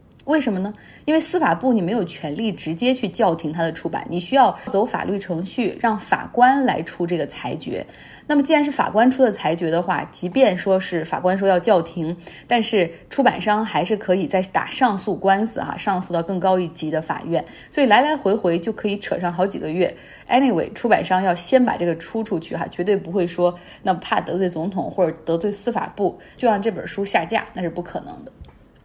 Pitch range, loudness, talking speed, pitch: 175-225 Hz, -21 LUFS, 320 characters per minute, 195 Hz